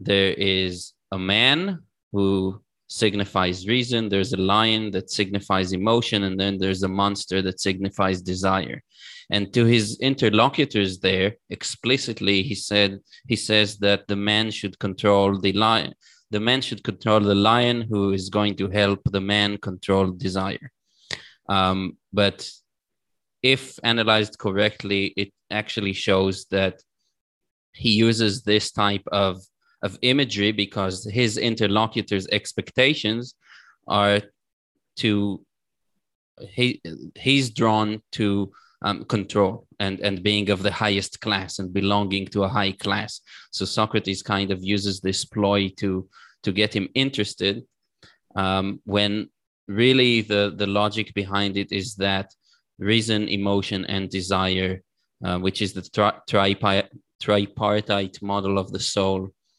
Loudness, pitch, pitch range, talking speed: -22 LUFS, 100 Hz, 95-110 Hz, 135 wpm